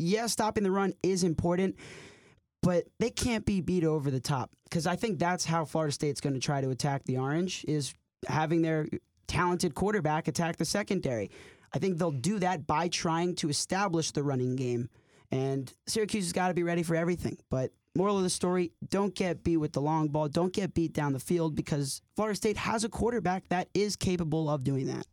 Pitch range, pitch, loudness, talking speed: 150-185 Hz, 170 Hz, -31 LUFS, 210 wpm